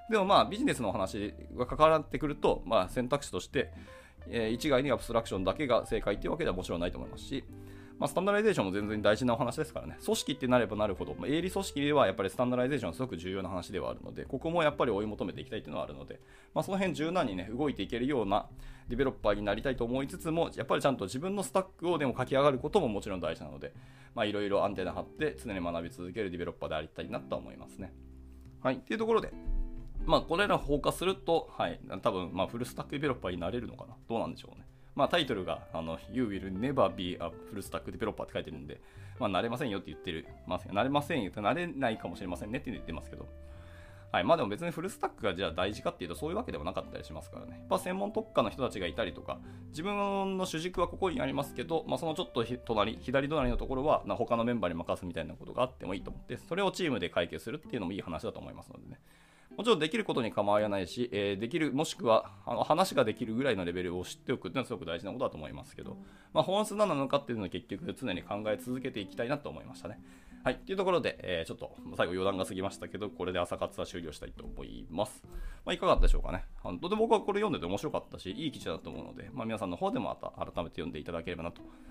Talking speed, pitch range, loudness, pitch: 560 characters per minute, 90-150 Hz, -33 LUFS, 115 Hz